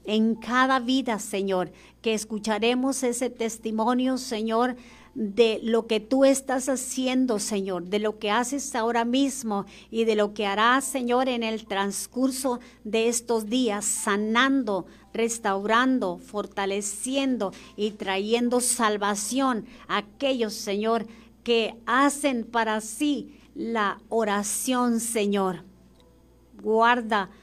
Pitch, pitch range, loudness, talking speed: 225 Hz, 210-250 Hz, -25 LUFS, 110 wpm